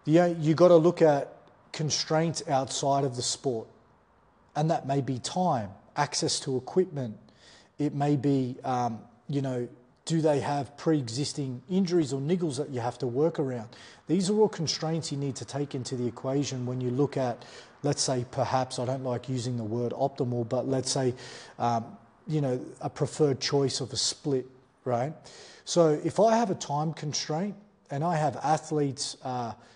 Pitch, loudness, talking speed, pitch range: 140 Hz, -28 LUFS, 180 wpm, 125-155 Hz